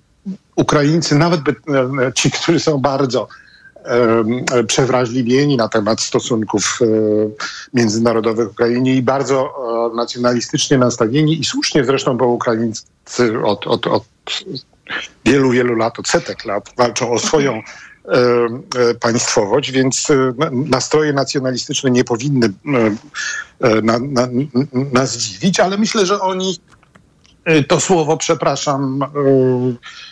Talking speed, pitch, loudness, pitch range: 120 wpm, 130 Hz, -16 LUFS, 120-145 Hz